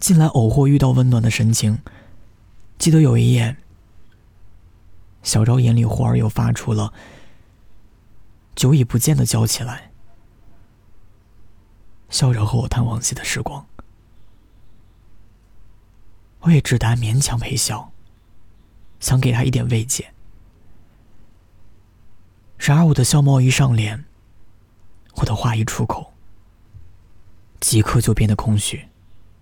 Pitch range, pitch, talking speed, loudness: 100-120 Hz, 110 Hz, 165 characters per minute, -18 LUFS